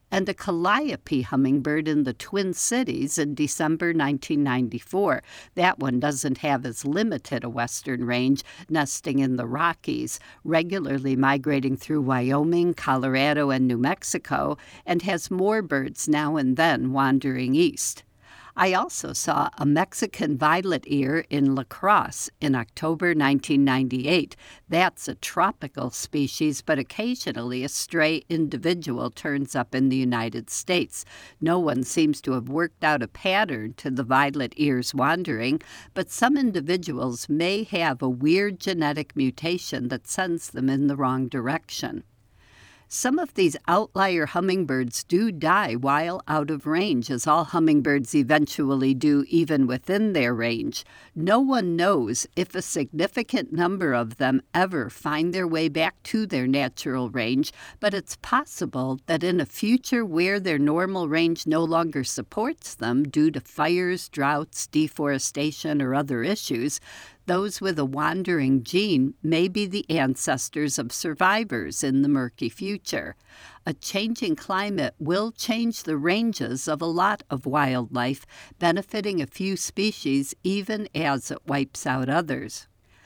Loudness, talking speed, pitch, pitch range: -24 LUFS, 145 wpm, 150 Hz, 135-180 Hz